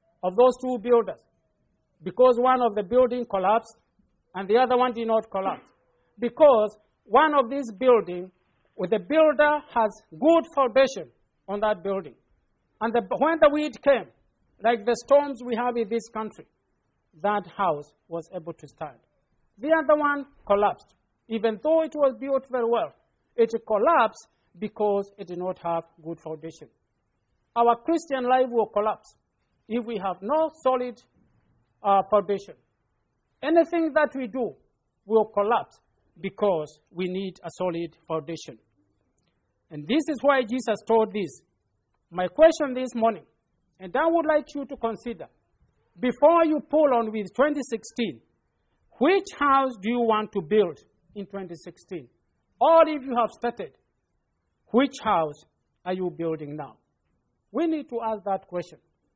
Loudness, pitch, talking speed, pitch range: -24 LUFS, 225 Hz, 150 wpm, 180-260 Hz